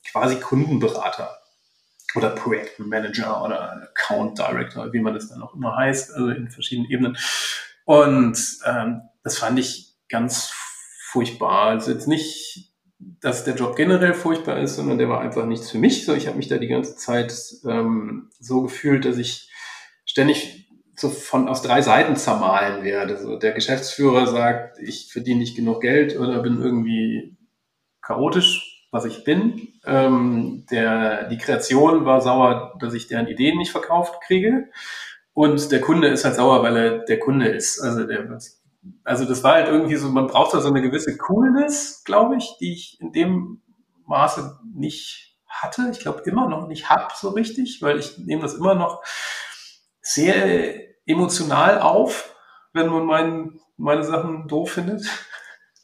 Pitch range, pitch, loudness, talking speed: 120-170 Hz, 140 Hz, -20 LUFS, 160 wpm